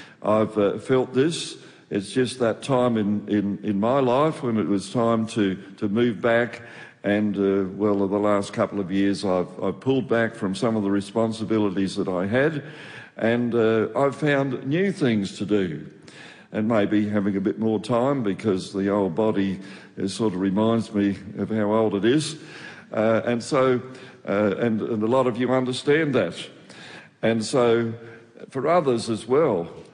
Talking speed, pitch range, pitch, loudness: 175 wpm, 100-125 Hz, 110 Hz, -23 LUFS